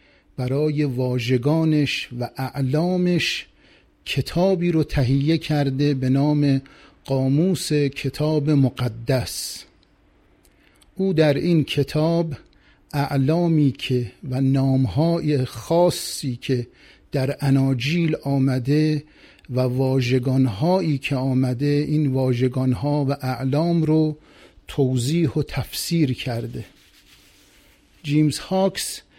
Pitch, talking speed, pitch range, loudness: 140 Hz, 85 wpm, 130-155 Hz, -21 LUFS